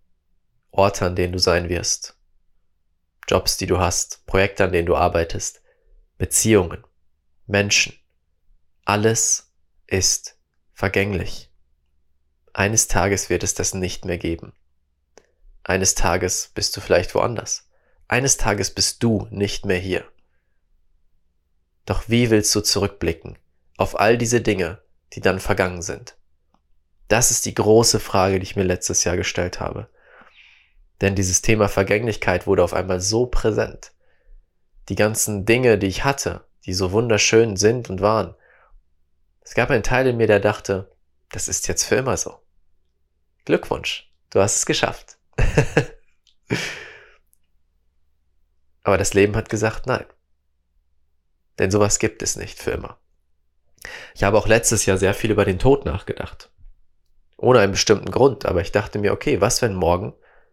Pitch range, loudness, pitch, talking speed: 75-105 Hz, -20 LUFS, 95 Hz, 140 wpm